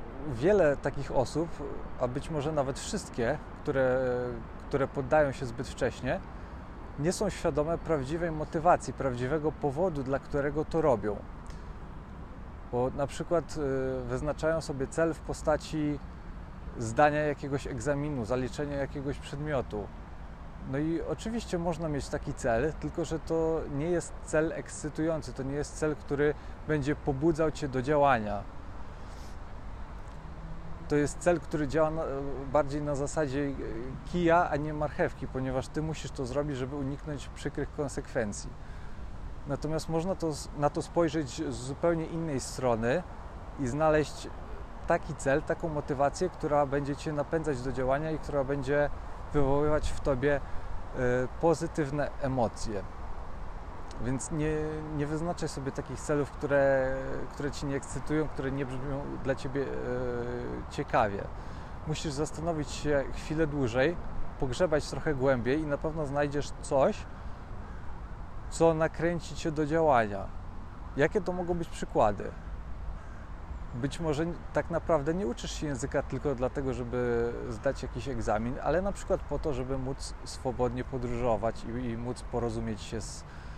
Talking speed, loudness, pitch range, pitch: 135 wpm, -31 LUFS, 125-155 Hz, 140 Hz